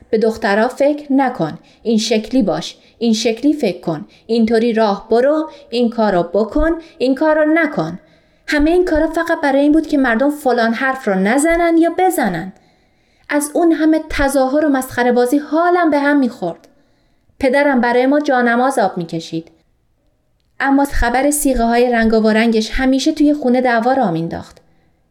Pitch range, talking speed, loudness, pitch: 225-295 Hz, 160 wpm, -15 LUFS, 260 Hz